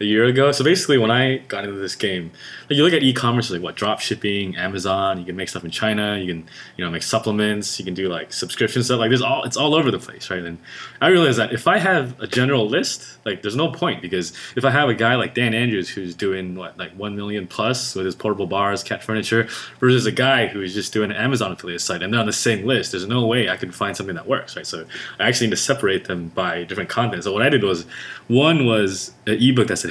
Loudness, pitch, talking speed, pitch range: -20 LUFS, 105 Hz, 265 wpm, 95-125 Hz